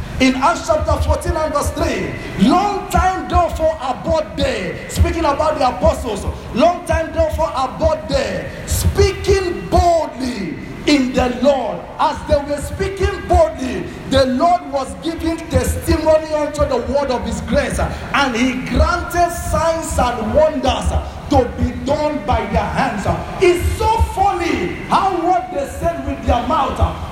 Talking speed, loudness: 140 wpm, -17 LUFS